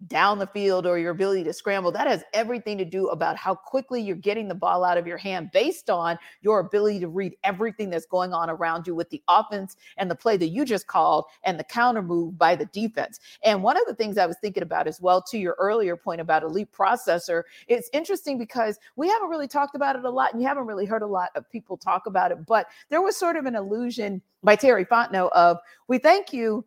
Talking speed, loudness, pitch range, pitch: 245 wpm, -24 LUFS, 180-240 Hz, 205 Hz